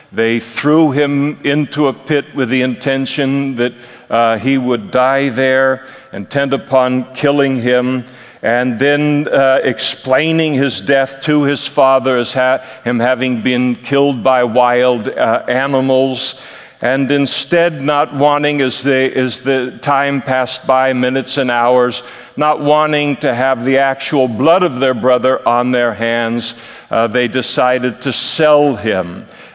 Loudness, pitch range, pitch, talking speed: -14 LUFS, 125-140 Hz, 130 Hz, 145 wpm